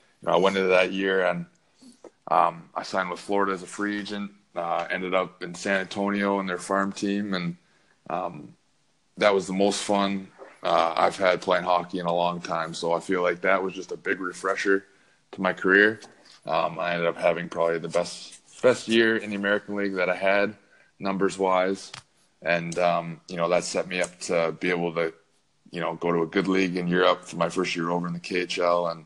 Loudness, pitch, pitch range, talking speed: -25 LUFS, 95 Hz, 85-100 Hz, 215 wpm